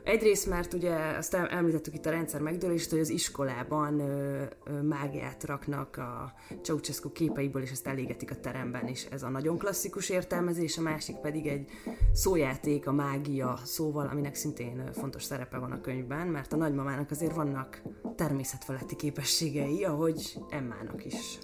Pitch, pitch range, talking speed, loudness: 145 Hz, 135-160 Hz, 155 wpm, -33 LUFS